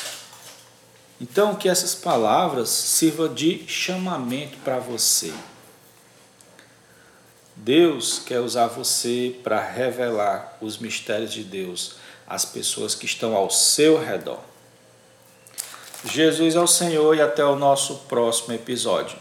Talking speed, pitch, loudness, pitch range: 110 wpm, 130 Hz, -21 LUFS, 115-160 Hz